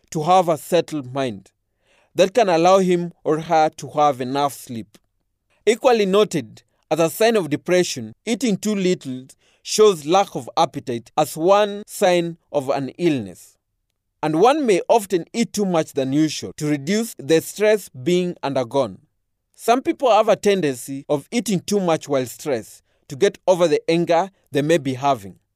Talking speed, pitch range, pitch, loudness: 165 wpm, 135-190 Hz, 160 Hz, -20 LUFS